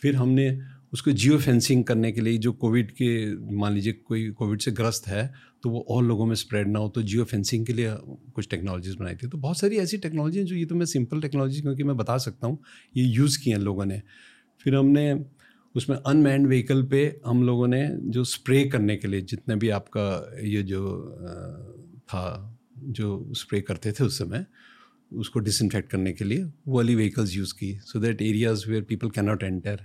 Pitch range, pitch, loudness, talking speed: 105-135 Hz, 120 Hz, -25 LUFS, 200 wpm